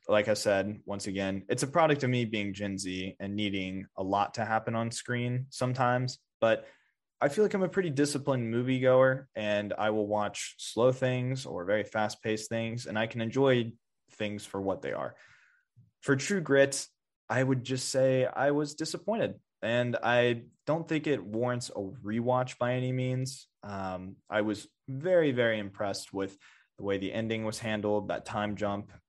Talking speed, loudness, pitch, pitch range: 180 wpm, -31 LUFS, 115 Hz, 105-130 Hz